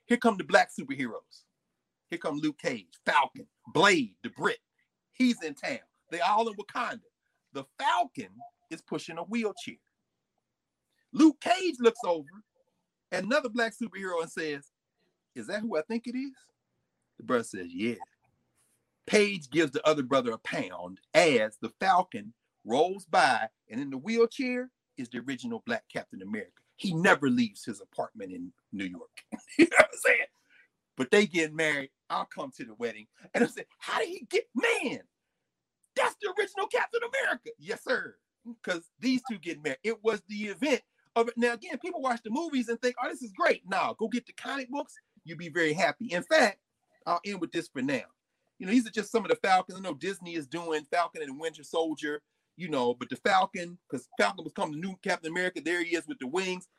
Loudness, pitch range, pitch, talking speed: -30 LUFS, 170-260 Hz, 230 Hz, 195 wpm